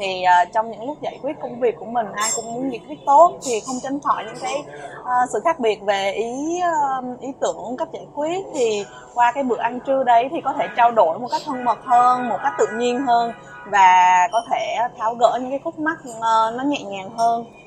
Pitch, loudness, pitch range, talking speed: 245 Hz, -20 LUFS, 225-285 Hz, 225 wpm